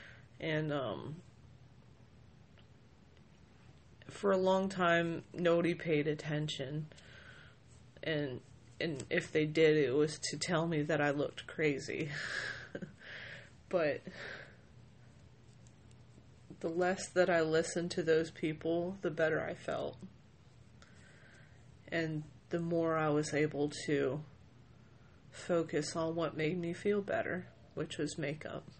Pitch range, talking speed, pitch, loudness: 140-165 Hz, 110 wpm, 155 Hz, -35 LUFS